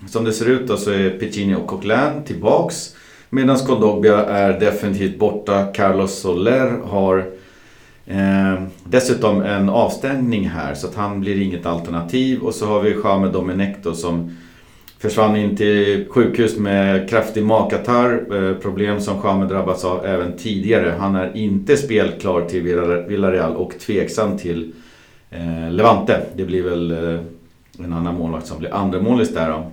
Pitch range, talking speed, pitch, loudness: 90-105 Hz, 150 wpm, 100 Hz, -18 LUFS